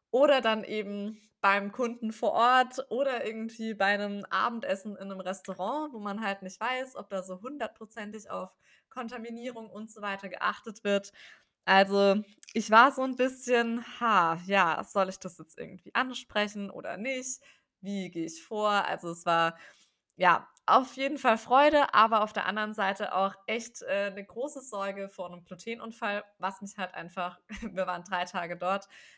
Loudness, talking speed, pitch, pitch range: -29 LUFS, 170 wpm, 210 Hz, 195-235 Hz